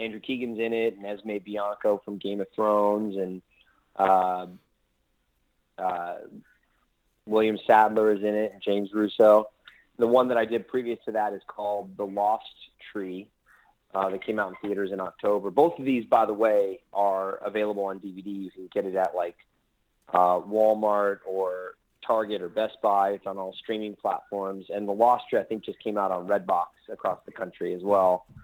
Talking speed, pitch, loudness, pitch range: 185 wpm, 100 Hz, -26 LUFS, 95-110 Hz